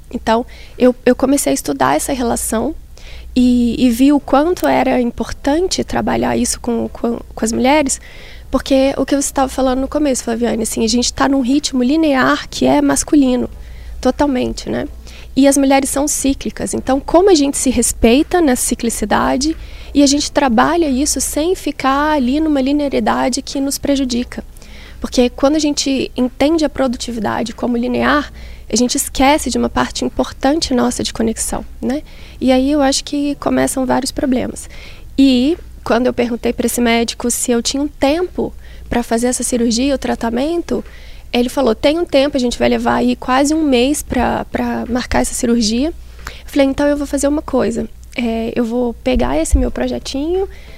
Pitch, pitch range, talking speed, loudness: 265 Hz, 240-285 Hz, 175 wpm, -15 LUFS